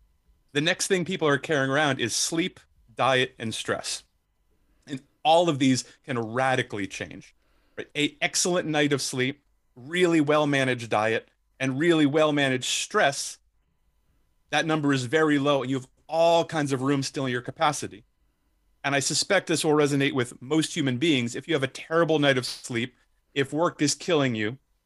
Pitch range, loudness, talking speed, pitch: 130-155 Hz, -25 LUFS, 175 wpm, 140 Hz